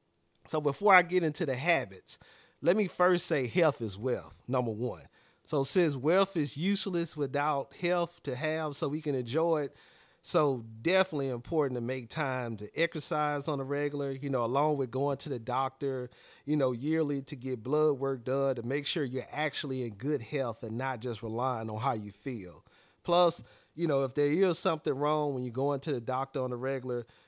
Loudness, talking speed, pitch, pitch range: -31 LUFS, 200 wpm, 140 Hz, 130-155 Hz